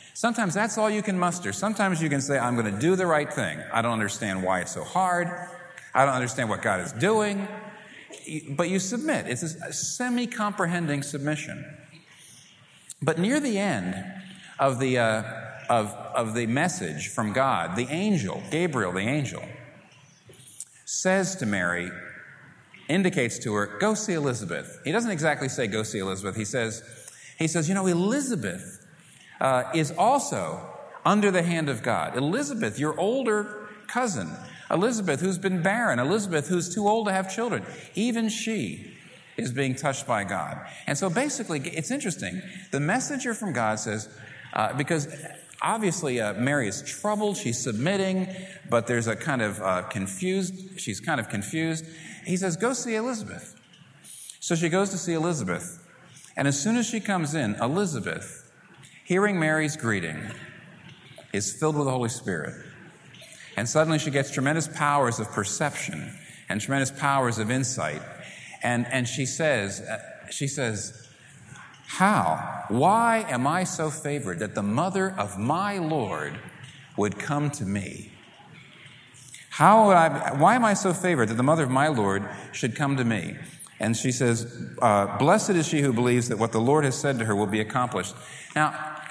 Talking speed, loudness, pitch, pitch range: 165 wpm, -26 LUFS, 150 Hz, 120-190 Hz